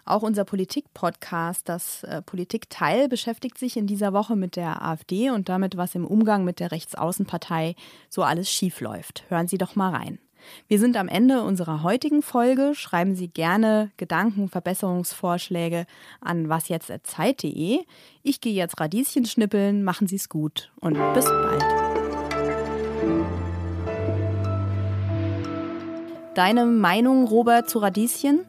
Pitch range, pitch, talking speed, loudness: 165-235 Hz, 190 Hz, 125 wpm, -24 LUFS